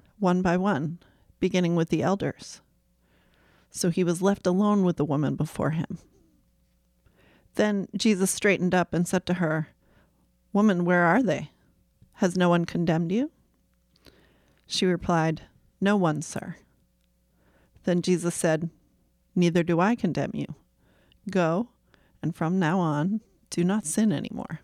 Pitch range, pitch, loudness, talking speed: 155-190 Hz, 175 Hz, -26 LUFS, 140 wpm